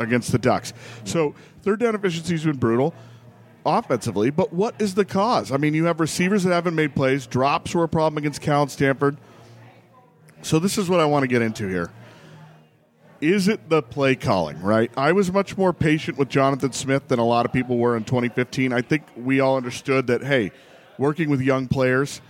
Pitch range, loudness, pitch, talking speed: 125-165 Hz, -22 LUFS, 140 Hz, 205 wpm